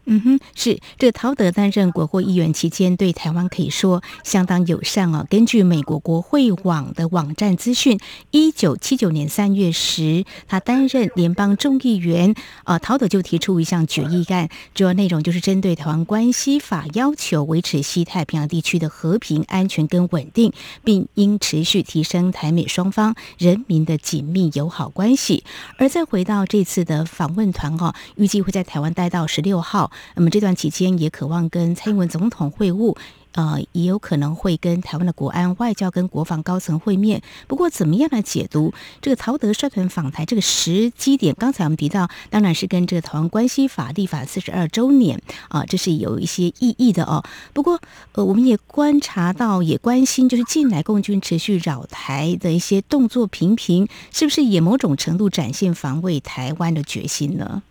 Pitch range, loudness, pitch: 165-210 Hz, -19 LUFS, 185 Hz